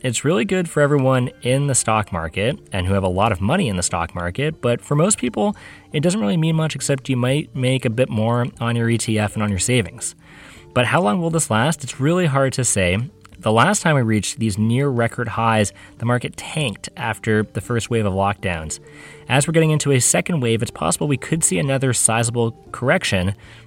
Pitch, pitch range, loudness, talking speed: 120 Hz, 110-145 Hz, -19 LUFS, 220 wpm